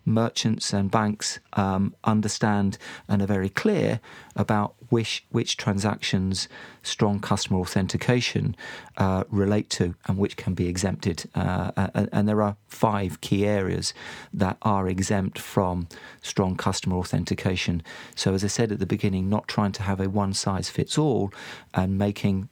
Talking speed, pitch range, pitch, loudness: 150 wpm, 95-105 Hz, 100 Hz, -25 LUFS